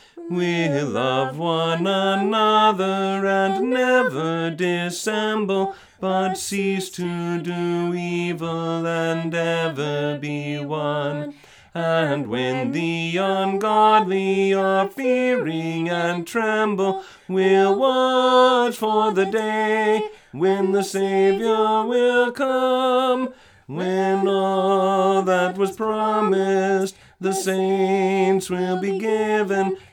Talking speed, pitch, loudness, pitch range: 90 wpm, 195 Hz, -21 LUFS, 170-215 Hz